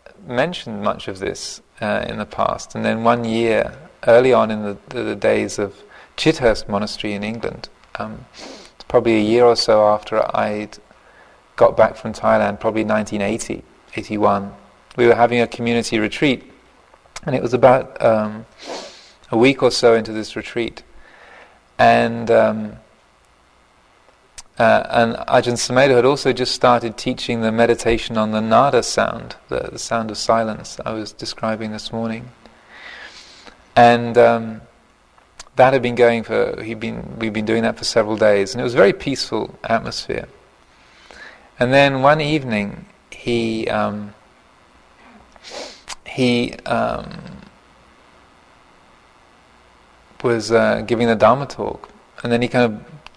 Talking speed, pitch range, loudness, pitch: 140 wpm, 110-120 Hz, -18 LUFS, 115 Hz